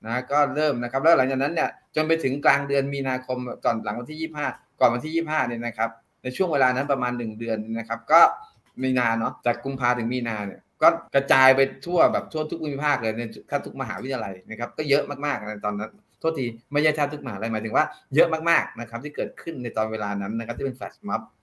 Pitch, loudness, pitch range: 130 Hz, -24 LUFS, 115-145 Hz